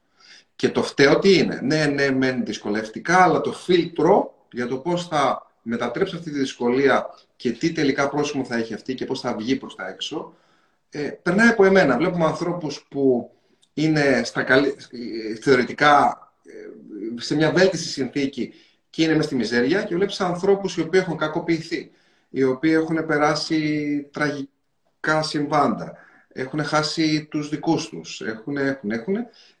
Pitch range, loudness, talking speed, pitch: 135-165 Hz, -21 LUFS, 150 wpm, 150 Hz